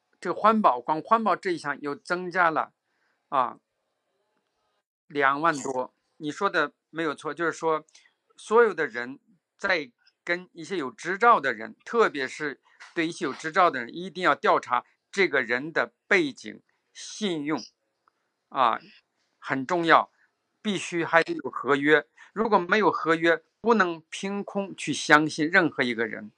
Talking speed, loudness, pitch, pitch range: 210 characters per minute, -25 LUFS, 170 Hz, 150-200 Hz